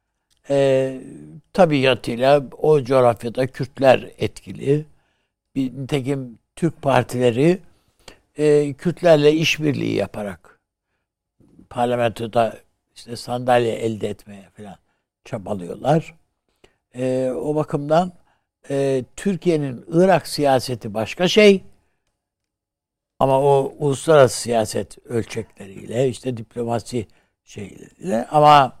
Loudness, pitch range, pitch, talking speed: -19 LUFS, 120-150 Hz, 135 Hz, 80 wpm